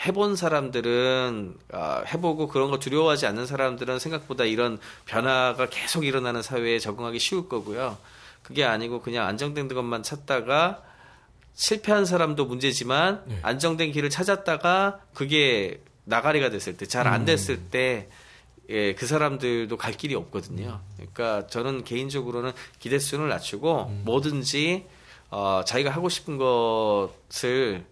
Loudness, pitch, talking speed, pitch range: -25 LUFS, 130 Hz, 310 characters per minute, 115-150 Hz